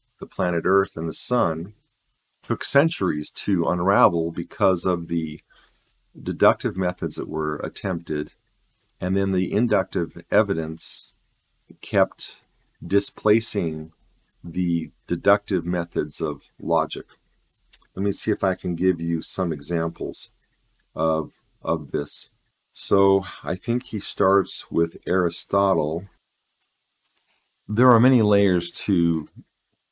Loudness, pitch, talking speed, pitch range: -23 LUFS, 90 Hz, 110 wpm, 80-100 Hz